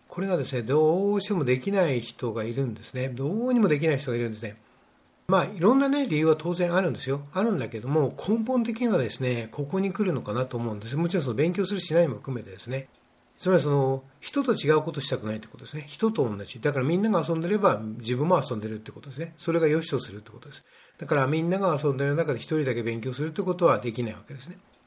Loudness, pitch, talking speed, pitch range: -26 LUFS, 145 Hz, 510 characters per minute, 125-180 Hz